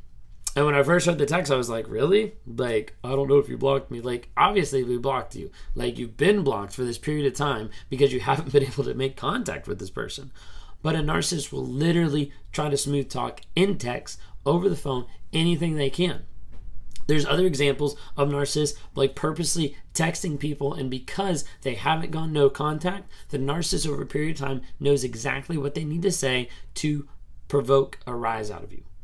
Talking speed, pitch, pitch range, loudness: 200 wpm, 140 Hz, 125-155 Hz, -25 LUFS